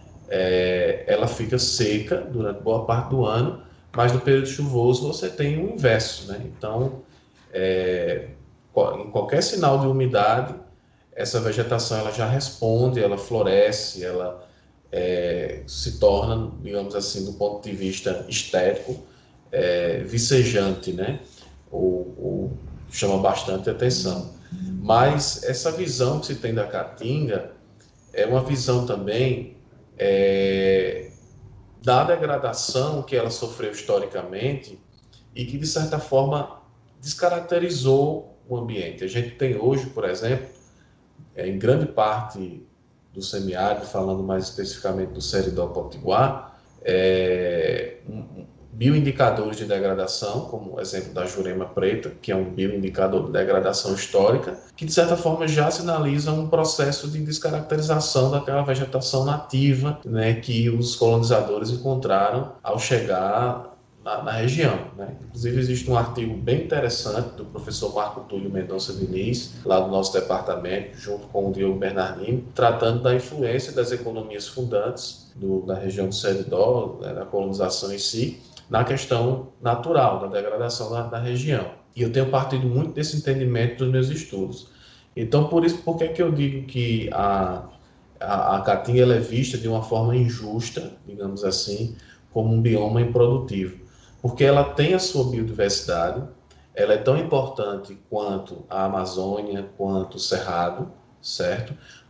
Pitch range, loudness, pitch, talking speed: 100-135 Hz, -23 LUFS, 120 Hz, 140 wpm